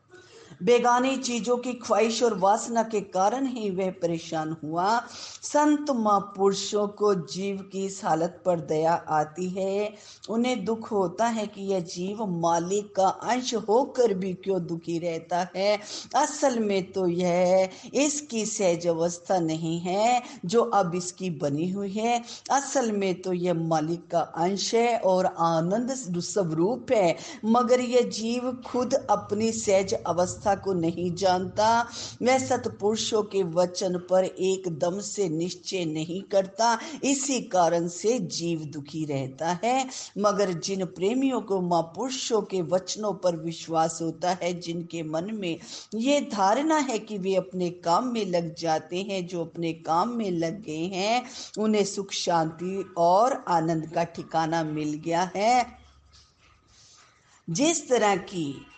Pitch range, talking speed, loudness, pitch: 175-225 Hz, 140 wpm, -26 LUFS, 195 Hz